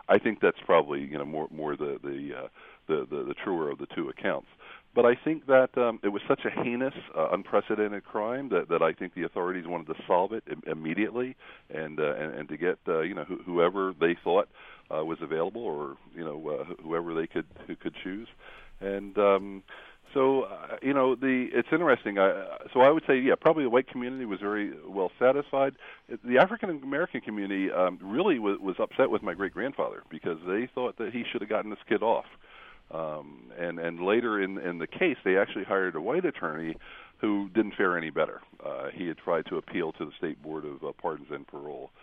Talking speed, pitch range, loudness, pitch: 215 wpm, 90-130 Hz, -29 LUFS, 105 Hz